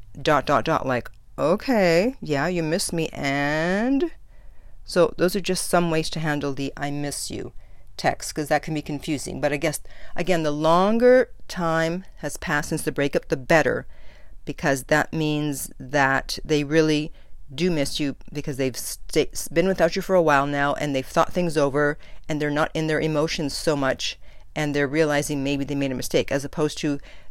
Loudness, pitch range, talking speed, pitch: -23 LUFS, 145-170 Hz, 185 wpm, 150 Hz